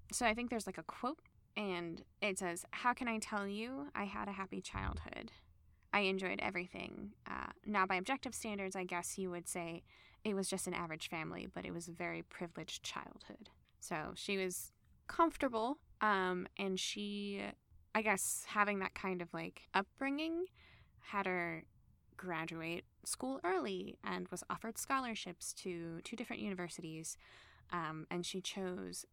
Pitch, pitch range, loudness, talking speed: 190 Hz, 175-215 Hz, -41 LUFS, 160 wpm